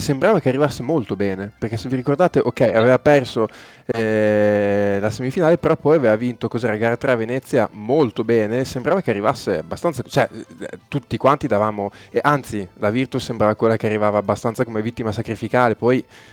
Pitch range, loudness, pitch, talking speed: 110-130 Hz, -19 LUFS, 120 Hz, 175 wpm